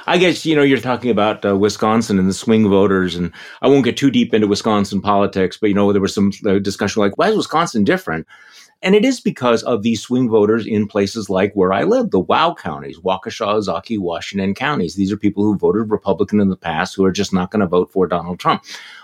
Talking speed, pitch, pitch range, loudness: 235 wpm, 105 Hz, 95-115 Hz, -17 LUFS